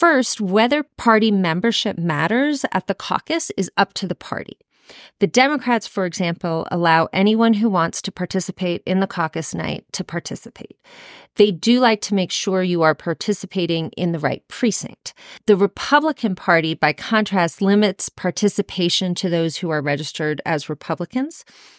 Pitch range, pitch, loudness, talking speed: 170-225 Hz, 190 Hz, -19 LUFS, 155 wpm